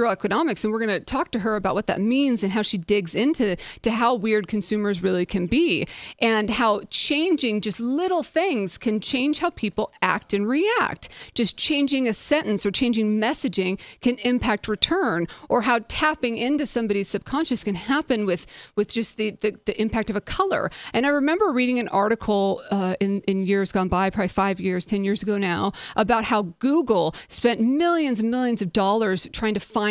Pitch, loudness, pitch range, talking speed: 220 Hz, -22 LUFS, 200-255 Hz, 195 wpm